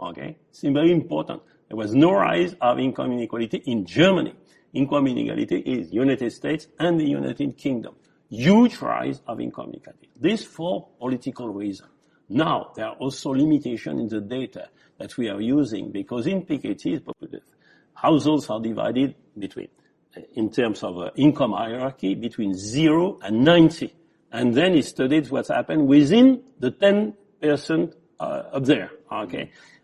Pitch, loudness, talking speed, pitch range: 140 Hz, -22 LUFS, 145 wpm, 120-170 Hz